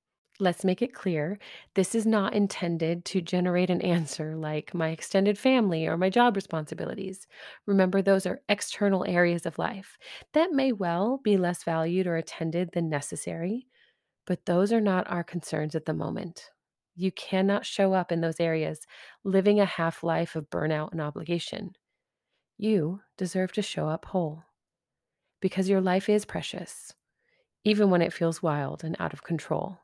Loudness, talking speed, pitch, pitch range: -28 LUFS, 165 wpm, 180 Hz, 165-200 Hz